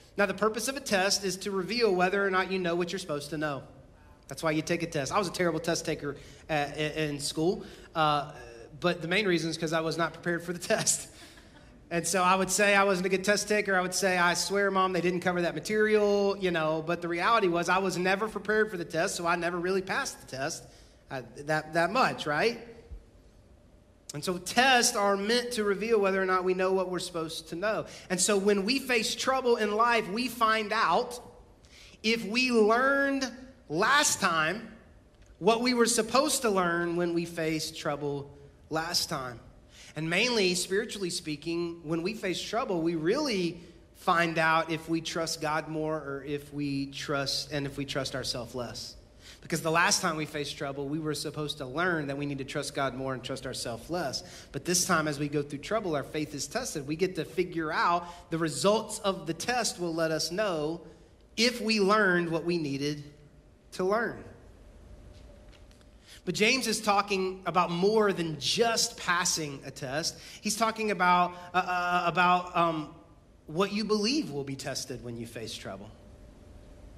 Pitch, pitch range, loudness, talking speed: 170 Hz, 150-200 Hz, -28 LUFS, 195 wpm